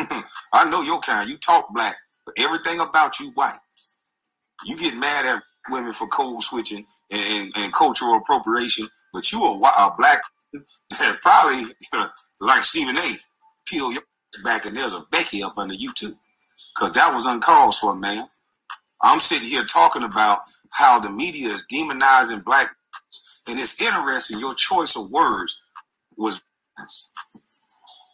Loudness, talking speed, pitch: -16 LUFS, 150 wpm, 145 Hz